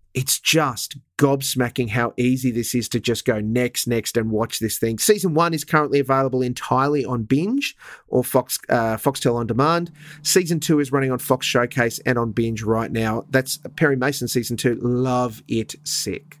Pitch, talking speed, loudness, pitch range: 130 Hz, 185 wpm, -21 LUFS, 120-145 Hz